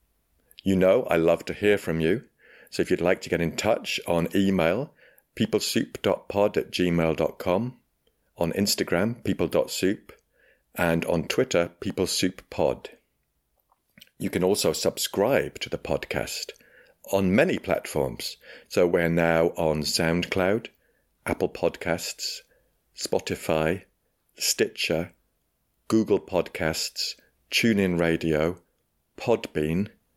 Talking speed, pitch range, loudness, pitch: 105 wpm, 80-95 Hz, -25 LUFS, 85 Hz